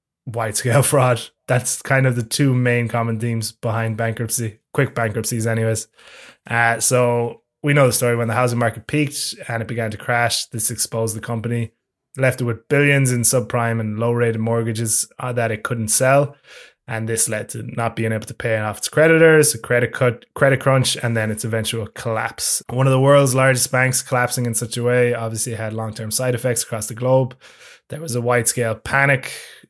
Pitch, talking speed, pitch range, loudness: 120 Hz, 190 wpm, 115-130 Hz, -18 LUFS